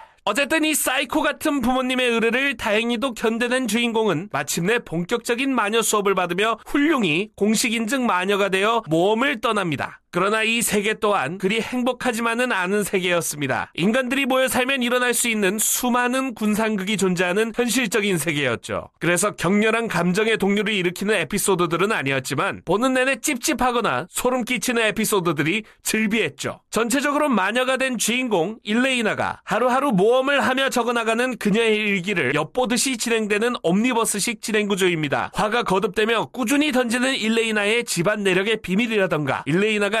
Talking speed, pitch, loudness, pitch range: 390 characters per minute, 225 Hz, -21 LUFS, 200-250 Hz